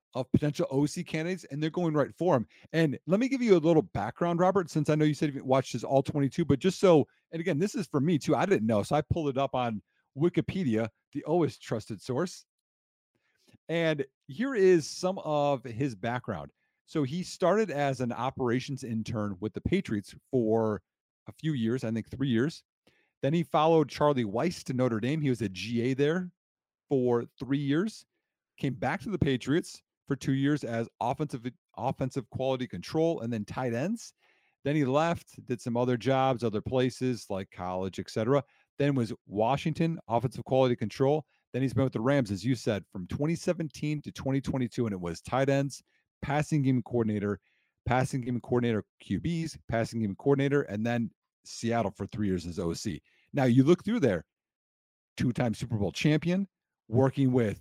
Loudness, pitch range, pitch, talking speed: -30 LUFS, 115-155 Hz, 135 Hz, 185 wpm